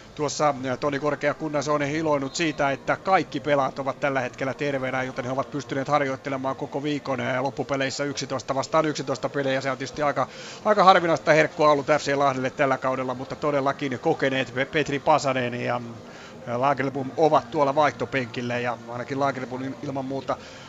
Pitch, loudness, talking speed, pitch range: 140 Hz, -24 LUFS, 155 wpm, 130-145 Hz